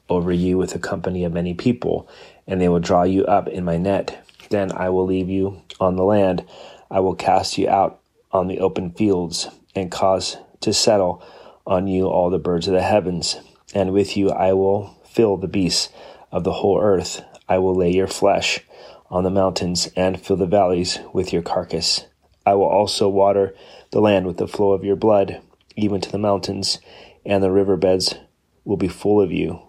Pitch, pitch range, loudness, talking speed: 95 Hz, 90-100 Hz, -20 LUFS, 195 wpm